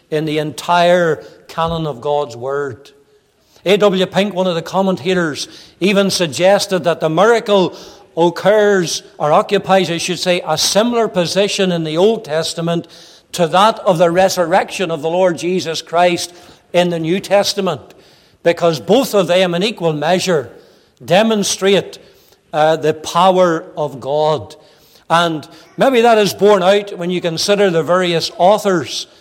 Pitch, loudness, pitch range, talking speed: 180 Hz, -15 LUFS, 165-195 Hz, 145 wpm